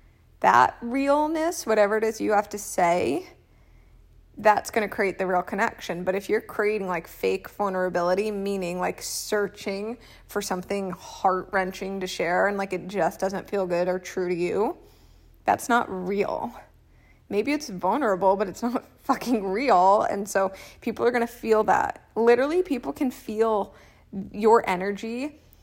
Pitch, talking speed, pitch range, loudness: 200 Hz, 155 wpm, 190-230 Hz, -25 LUFS